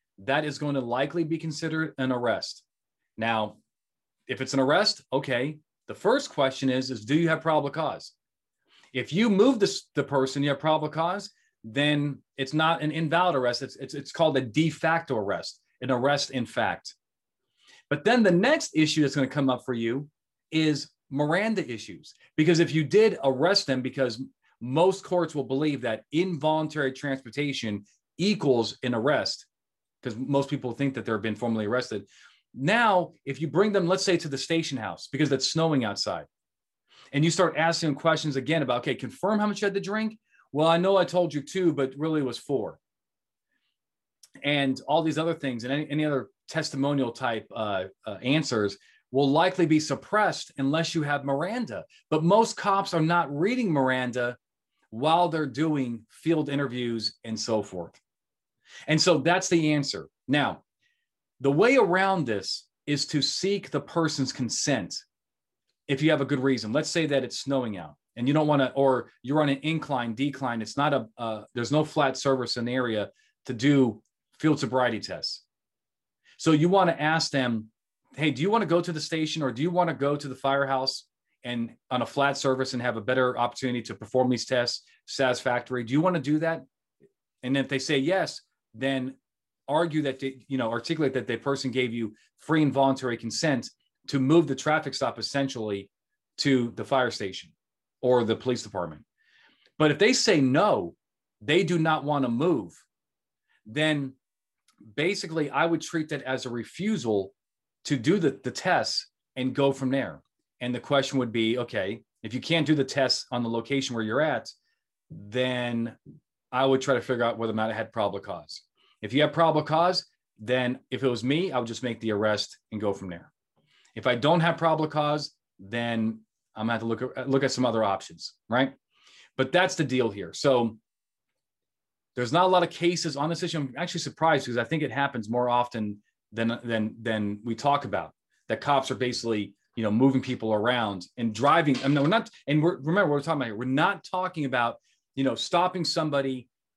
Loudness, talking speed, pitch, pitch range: -26 LUFS, 190 wpm, 140 Hz, 125-160 Hz